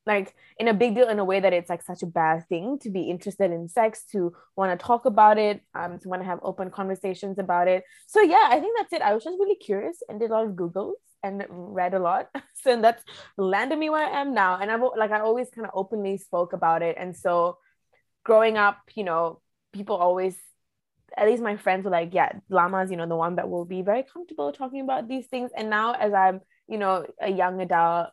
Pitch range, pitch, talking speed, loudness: 180-230 Hz, 200 Hz, 245 wpm, -24 LUFS